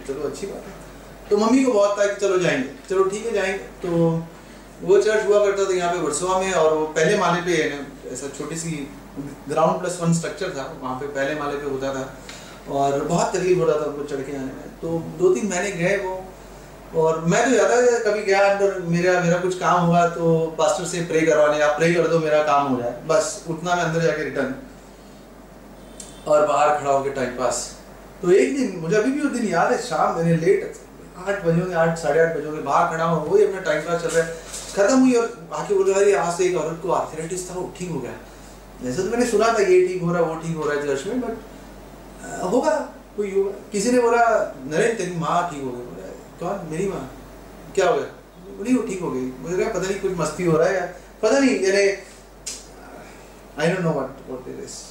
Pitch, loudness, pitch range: 175 Hz, -21 LUFS, 155-200 Hz